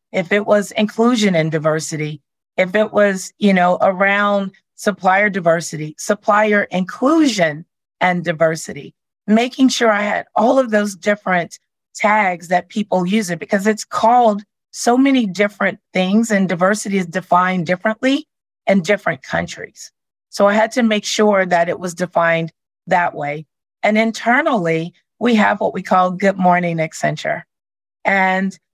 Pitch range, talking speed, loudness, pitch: 180-215 Hz, 145 wpm, -16 LUFS, 195 Hz